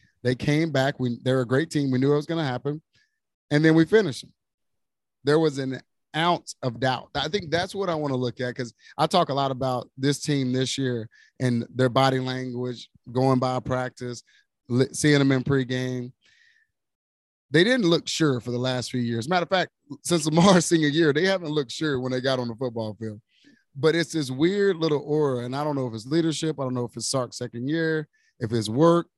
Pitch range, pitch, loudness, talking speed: 125-160 Hz, 135 Hz, -24 LUFS, 220 wpm